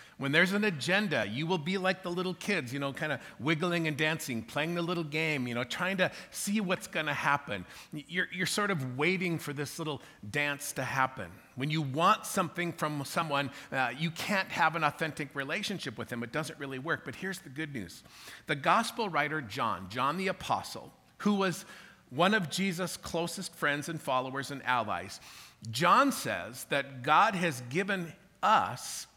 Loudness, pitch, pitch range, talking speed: -31 LUFS, 155 Hz, 140-185 Hz, 185 wpm